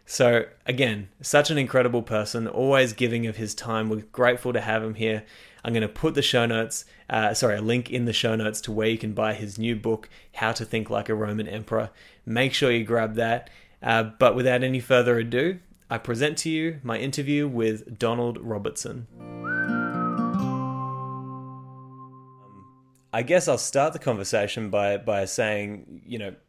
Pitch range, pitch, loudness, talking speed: 110-130 Hz, 115 Hz, -25 LUFS, 180 wpm